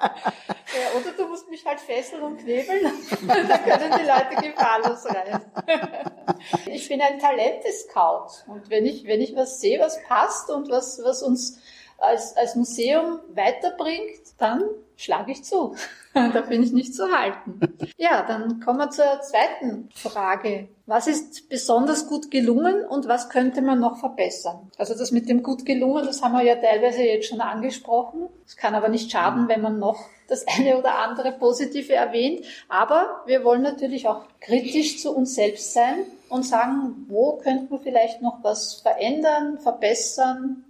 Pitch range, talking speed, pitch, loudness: 230-295 Hz, 165 wpm, 255 Hz, -23 LUFS